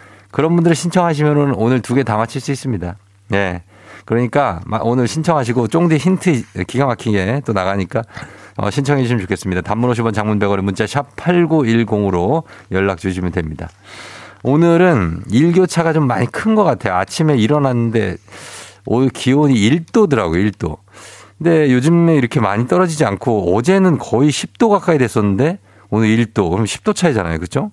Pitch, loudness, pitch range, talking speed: 120 Hz, -15 LUFS, 100-150 Hz, 340 characters per minute